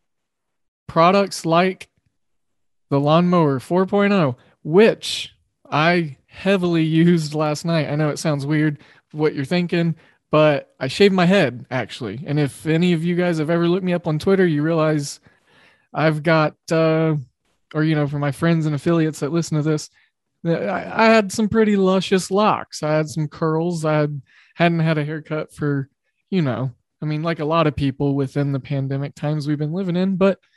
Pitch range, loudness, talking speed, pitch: 145-175 Hz, -19 LUFS, 175 wpm, 155 Hz